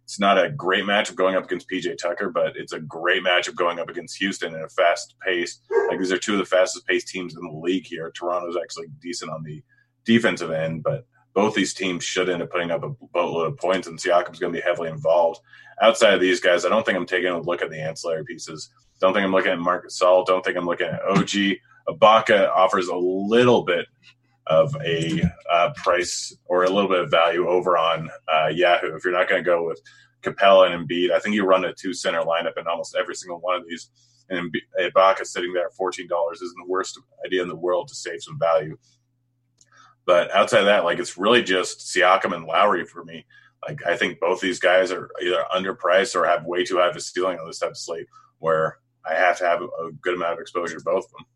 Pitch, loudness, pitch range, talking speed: 95 Hz, -22 LUFS, 85-115 Hz, 235 wpm